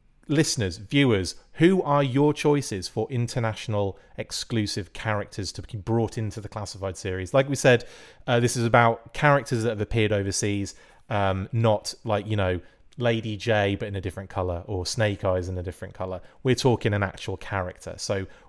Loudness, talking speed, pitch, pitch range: -25 LUFS, 175 wpm, 105 Hz, 95-120 Hz